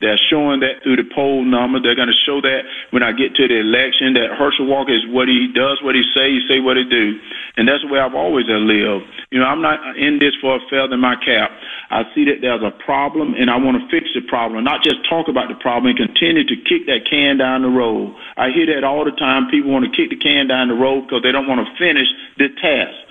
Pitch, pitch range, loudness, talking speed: 135 Hz, 125-145 Hz, -15 LUFS, 265 wpm